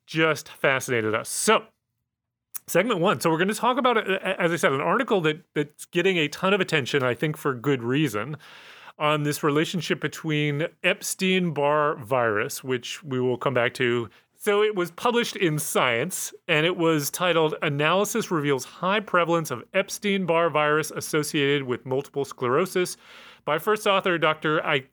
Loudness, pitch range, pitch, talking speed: -24 LUFS, 145-185 Hz, 160 Hz, 160 wpm